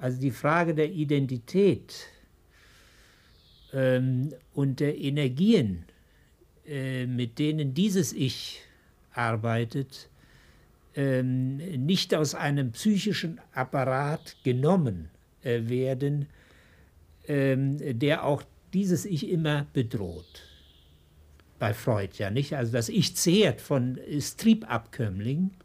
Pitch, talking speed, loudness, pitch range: 130 Hz, 95 wpm, -28 LUFS, 105-150 Hz